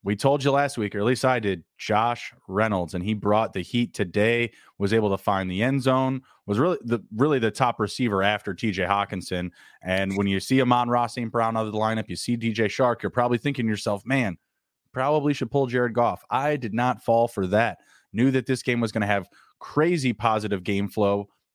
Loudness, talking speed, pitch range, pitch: -24 LUFS, 225 wpm, 100-125 Hz, 115 Hz